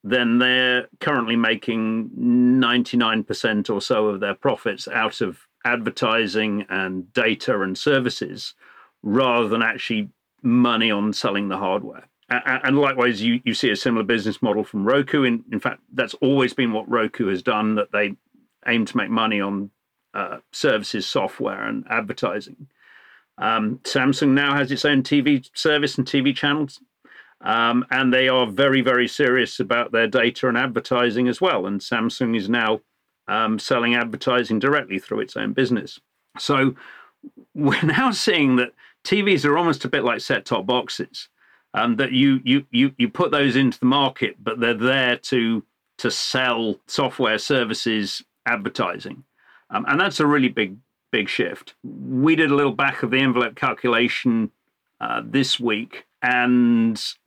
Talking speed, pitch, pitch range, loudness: 160 wpm, 125 Hz, 115-140 Hz, -21 LUFS